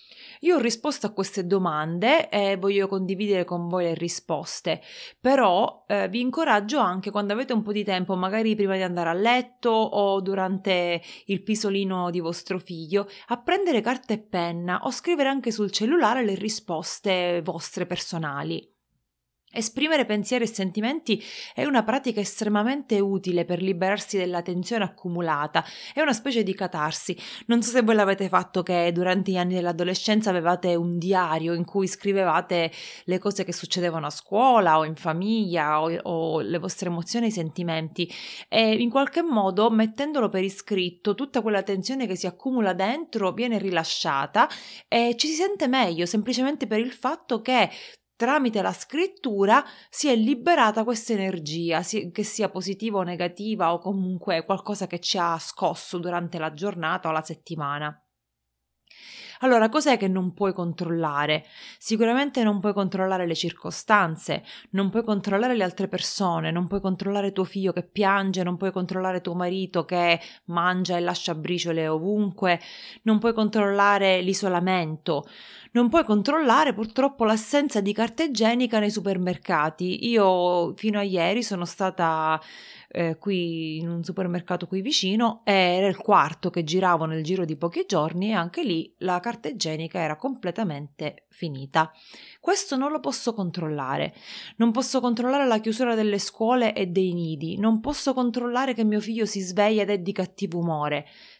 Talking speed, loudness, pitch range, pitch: 155 wpm, -25 LUFS, 175-225 Hz, 195 Hz